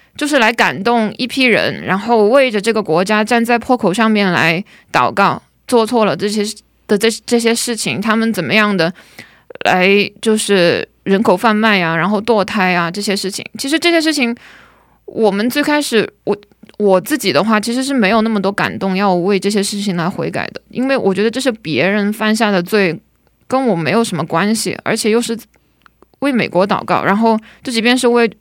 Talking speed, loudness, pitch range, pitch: 285 characters per minute, -14 LUFS, 195-235 Hz, 215 Hz